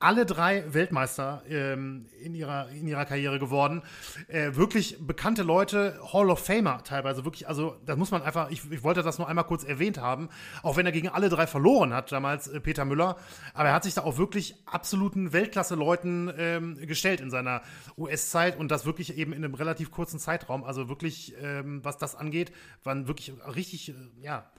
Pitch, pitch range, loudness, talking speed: 160 Hz, 140-175 Hz, -29 LUFS, 195 wpm